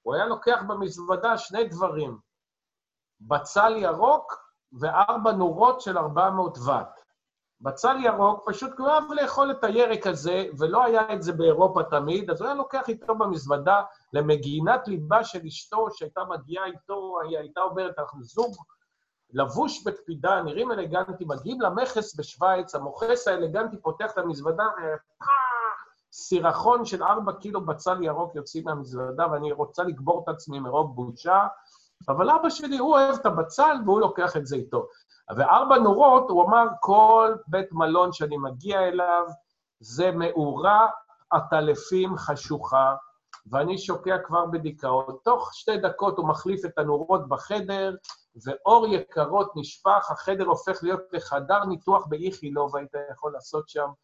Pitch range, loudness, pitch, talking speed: 155-220 Hz, -24 LUFS, 185 Hz, 140 wpm